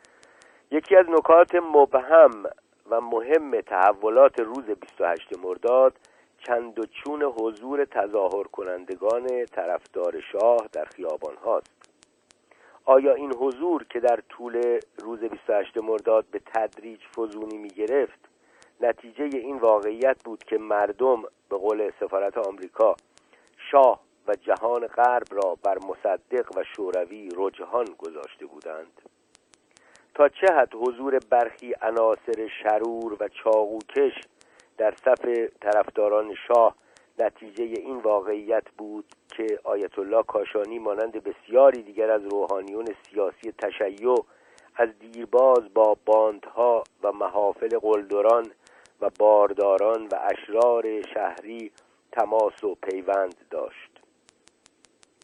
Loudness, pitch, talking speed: -24 LUFS, 130 Hz, 110 wpm